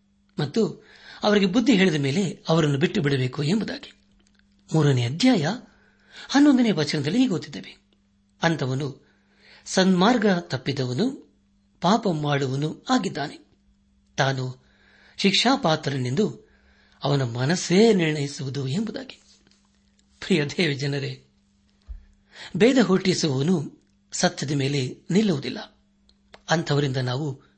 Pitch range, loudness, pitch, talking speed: 125-195 Hz, -23 LUFS, 150 Hz, 80 wpm